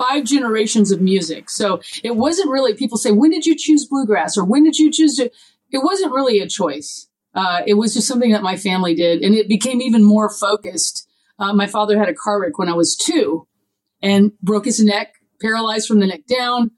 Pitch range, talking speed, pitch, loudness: 200-265 Hz, 220 wpm, 215 Hz, -16 LUFS